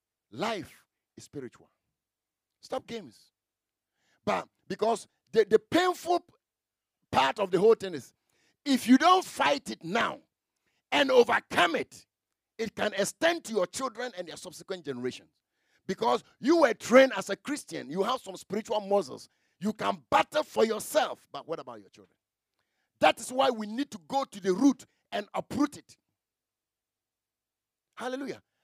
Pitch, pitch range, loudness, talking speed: 250 Hz, 200-290 Hz, -28 LUFS, 150 wpm